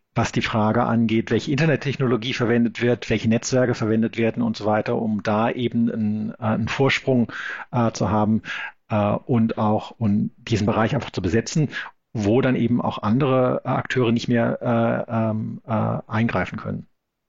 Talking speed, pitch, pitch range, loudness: 160 wpm, 115 Hz, 110-120 Hz, -22 LUFS